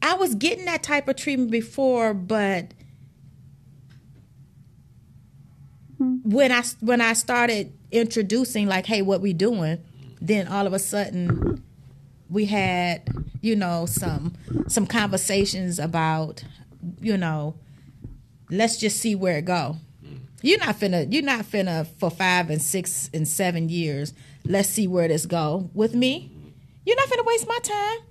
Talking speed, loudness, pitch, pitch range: 145 wpm, -23 LUFS, 180 Hz, 145-220 Hz